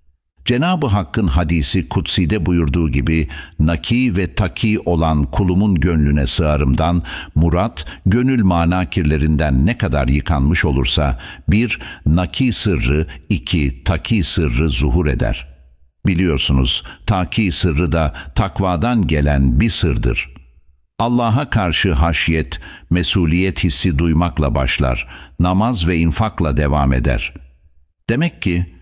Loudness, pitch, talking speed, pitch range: -17 LUFS, 85 Hz, 105 wpm, 75-95 Hz